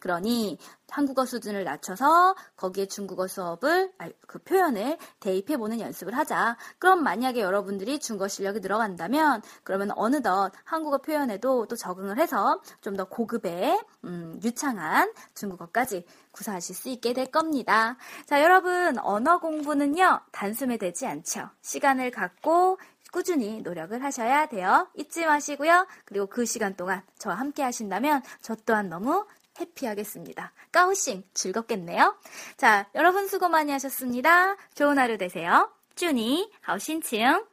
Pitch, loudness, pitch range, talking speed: 260 Hz, -26 LUFS, 205-320 Hz, 325 characters per minute